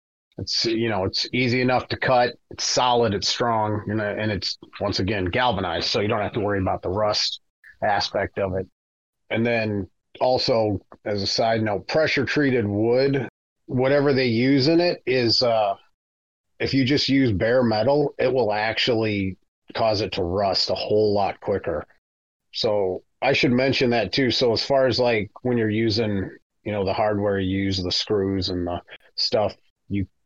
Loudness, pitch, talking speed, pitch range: -22 LUFS, 110 Hz, 180 wpm, 95-125 Hz